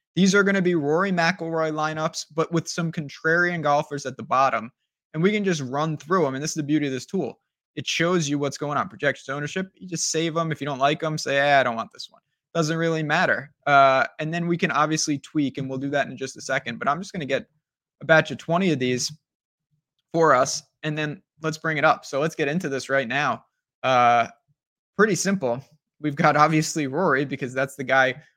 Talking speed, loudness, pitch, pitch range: 235 wpm, -23 LUFS, 155 Hz, 140-165 Hz